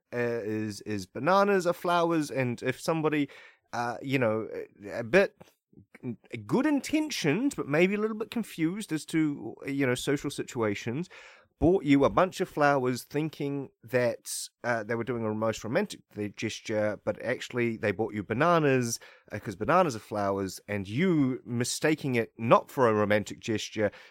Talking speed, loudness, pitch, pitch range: 160 wpm, -29 LUFS, 135 Hz, 110-160 Hz